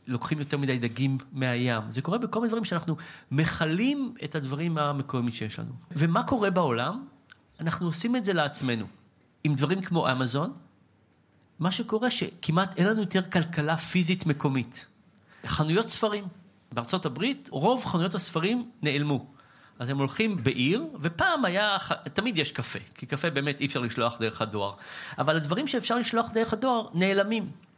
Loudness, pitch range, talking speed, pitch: -28 LUFS, 135-195 Hz, 150 wpm, 160 Hz